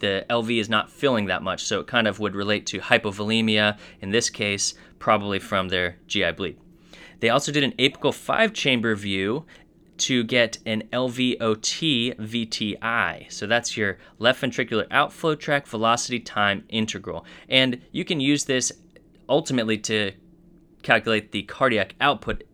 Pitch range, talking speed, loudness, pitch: 105-130 Hz, 150 wpm, -23 LUFS, 115 Hz